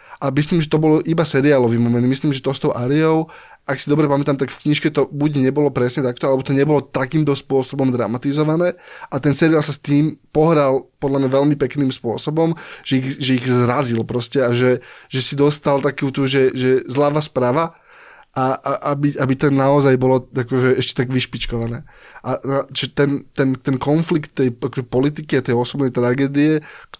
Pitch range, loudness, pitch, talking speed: 130-150 Hz, -18 LUFS, 140 Hz, 190 wpm